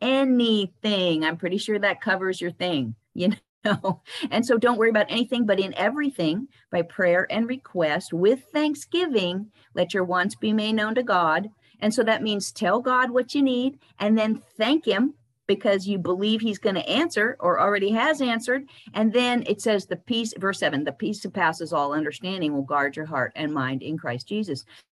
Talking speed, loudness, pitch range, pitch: 190 wpm, -24 LUFS, 175-235 Hz, 205 Hz